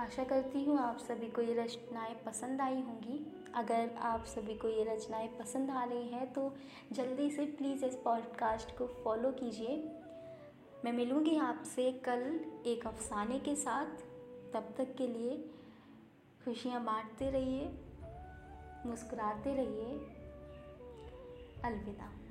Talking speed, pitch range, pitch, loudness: 130 wpm, 230-270 Hz, 245 Hz, -39 LUFS